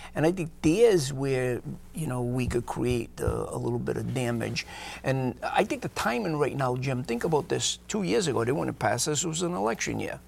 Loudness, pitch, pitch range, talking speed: -28 LUFS, 125 Hz, 120-155 Hz, 235 wpm